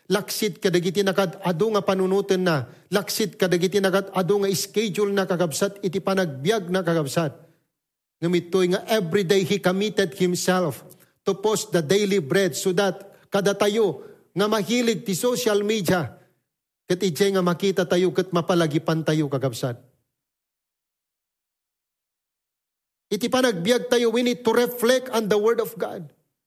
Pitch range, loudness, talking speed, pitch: 175-205 Hz, -23 LUFS, 140 wpm, 195 Hz